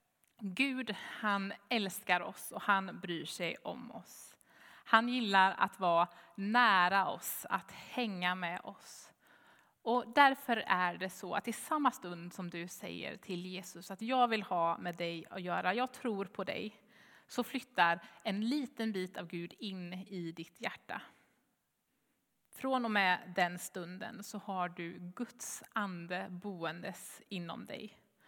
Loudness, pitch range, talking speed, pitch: -35 LUFS, 180-225 Hz, 150 wpm, 195 Hz